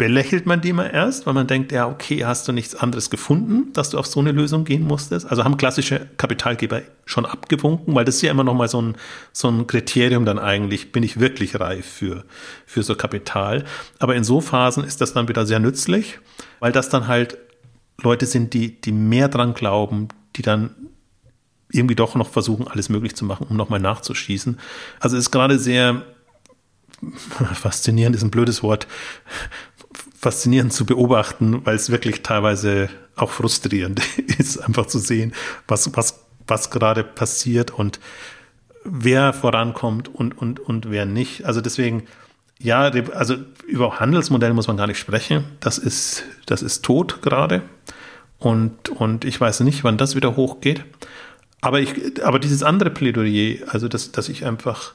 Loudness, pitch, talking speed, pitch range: -20 LUFS, 120 Hz, 170 wpm, 110-135 Hz